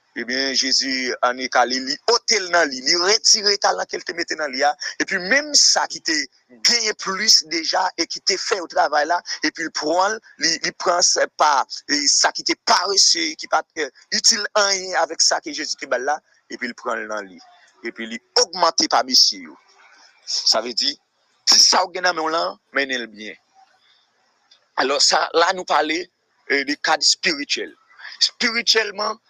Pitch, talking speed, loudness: 195 Hz, 185 wpm, -18 LUFS